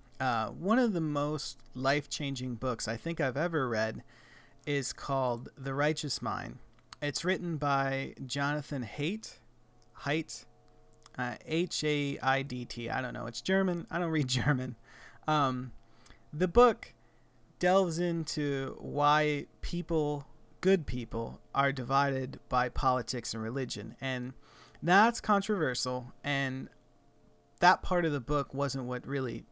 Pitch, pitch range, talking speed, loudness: 135 Hz, 125-155 Hz, 130 wpm, -32 LUFS